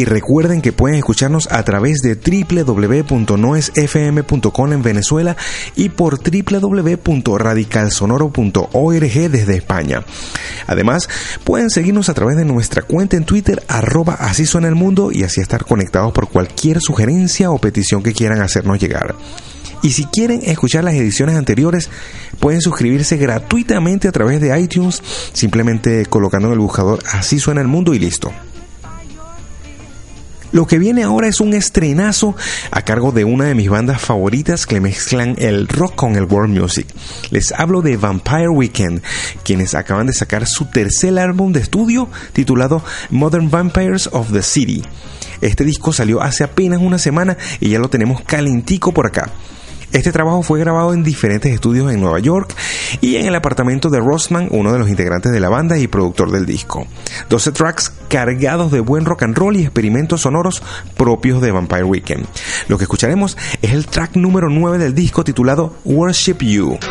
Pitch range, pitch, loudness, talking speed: 105-165 Hz, 135 Hz, -14 LUFS, 160 wpm